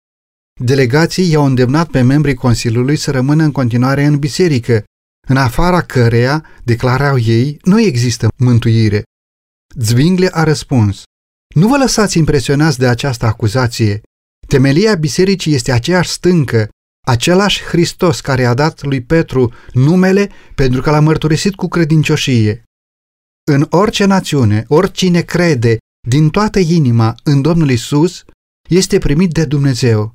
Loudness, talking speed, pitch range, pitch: -12 LUFS, 125 wpm, 120-165 Hz, 140 Hz